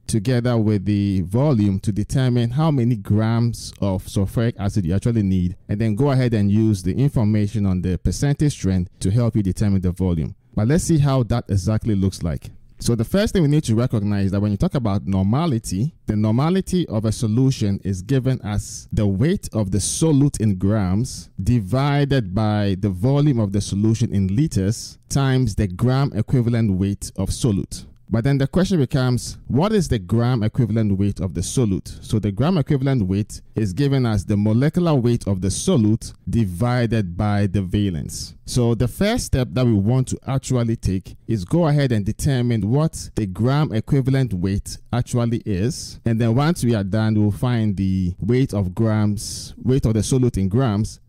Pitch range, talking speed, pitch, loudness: 100-130 Hz, 190 wpm, 110 Hz, -20 LUFS